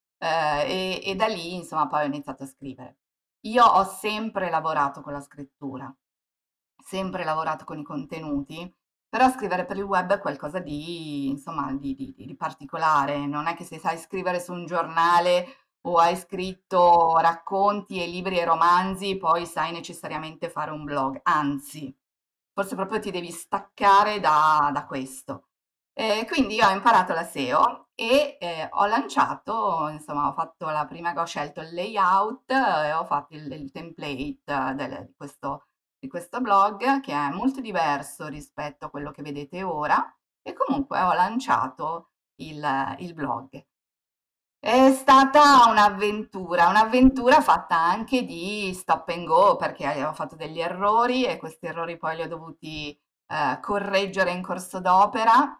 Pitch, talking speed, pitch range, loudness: 170 Hz, 155 wpm, 150-200 Hz, -23 LUFS